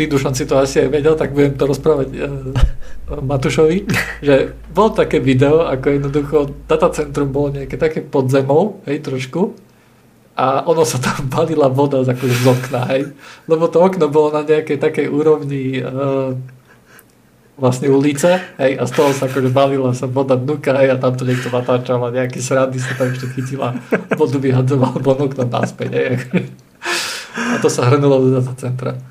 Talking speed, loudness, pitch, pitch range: 170 wpm, -16 LUFS, 140 Hz, 130-150 Hz